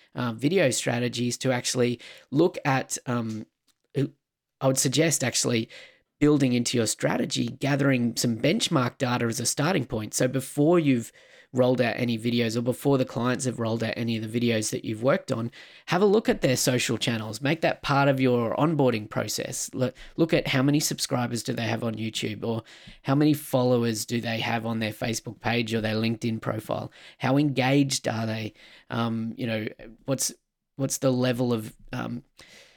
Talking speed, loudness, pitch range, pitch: 180 wpm, -26 LUFS, 115-135 Hz, 125 Hz